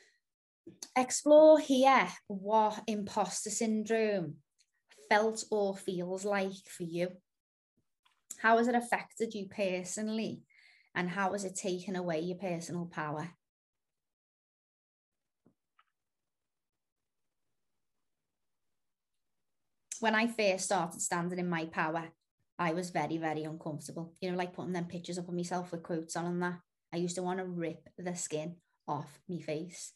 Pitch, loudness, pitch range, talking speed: 180 Hz, -33 LUFS, 170-210 Hz, 130 wpm